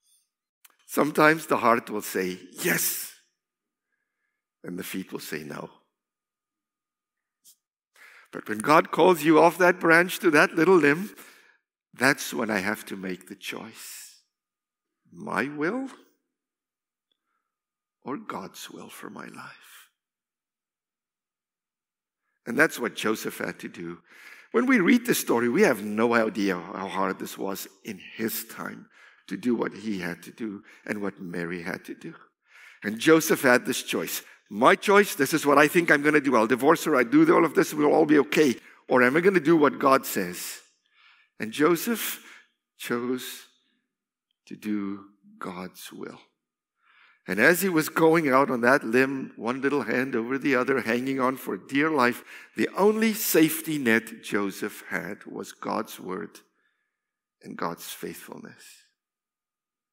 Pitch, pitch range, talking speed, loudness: 135 Hz, 105-160 Hz, 150 wpm, -24 LUFS